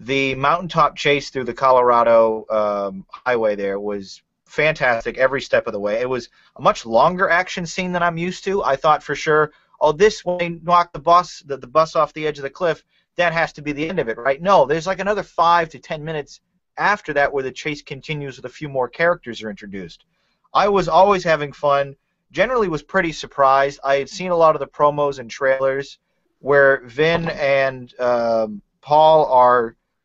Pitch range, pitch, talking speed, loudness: 130-170 Hz, 145 Hz, 200 wpm, -18 LUFS